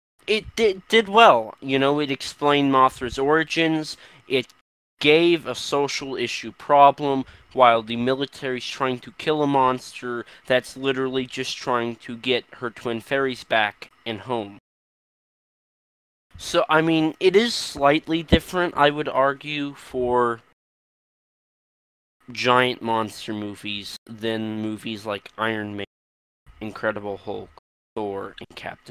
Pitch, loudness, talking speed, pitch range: 125 Hz, -22 LUFS, 125 wpm, 110-145 Hz